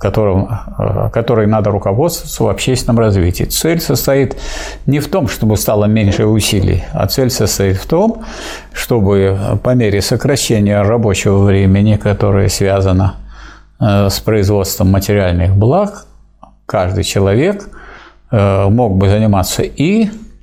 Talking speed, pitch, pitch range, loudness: 115 wpm, 105 Hz, 100-125 Hz, -13 LUFS